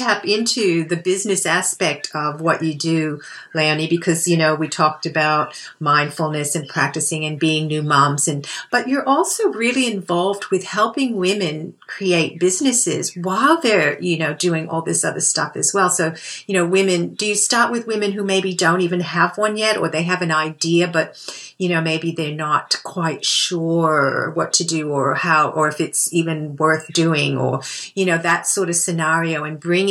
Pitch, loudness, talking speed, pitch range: 165 Hz, -18 LUFS, 185 wpm, 155-190 Hz